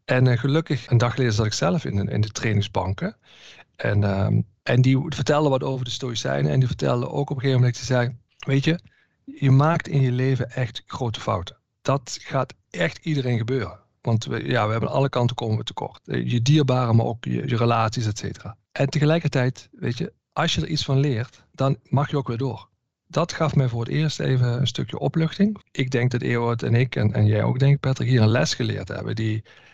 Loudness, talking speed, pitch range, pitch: -23 LUFS, 225 wpm, 115-140 Hz, 125 Hz